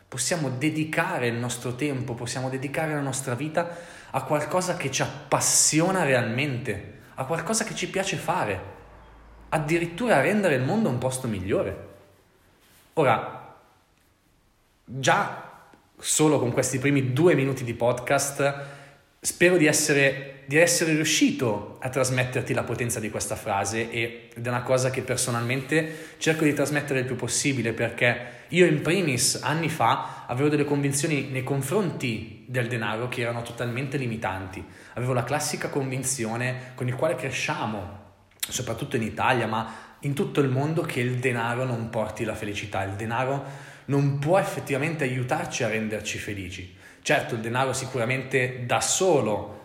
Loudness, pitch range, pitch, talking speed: -25 LUFS, 115-145 Hz, 130 Hz, 145 wpm